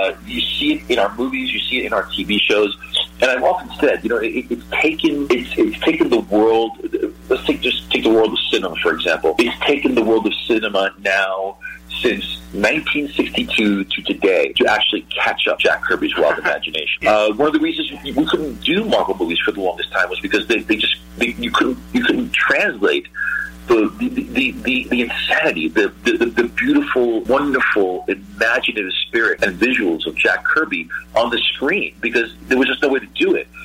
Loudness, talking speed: -17 LUFS, 200 wpm